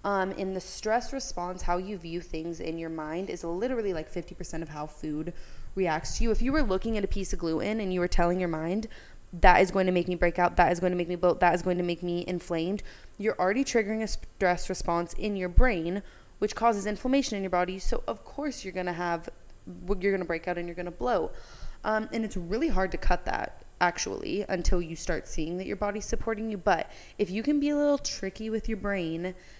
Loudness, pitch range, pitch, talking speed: -29 LUFS, 175-210 Hz, 185 Hz, 245 wpm